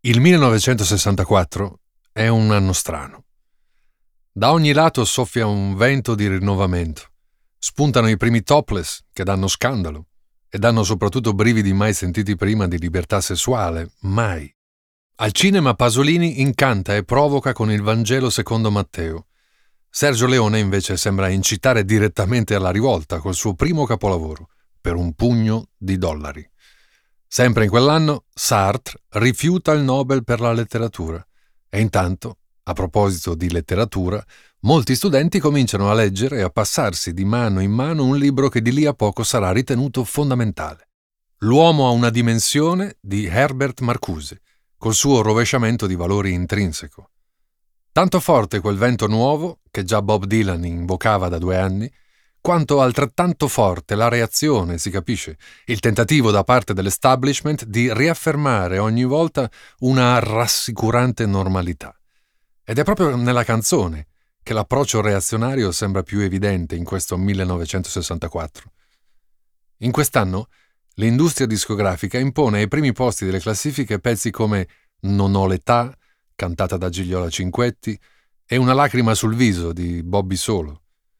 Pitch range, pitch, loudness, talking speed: 95-125 Hz, 110 Hz, -18 LUFS, 135 wpm